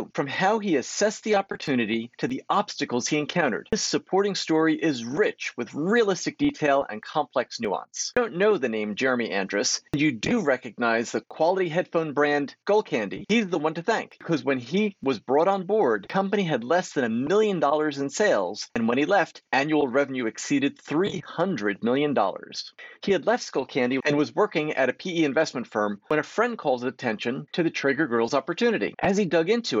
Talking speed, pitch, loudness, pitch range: 195 wpm, 160 Hz, -25 LUFS, 140-200 Hz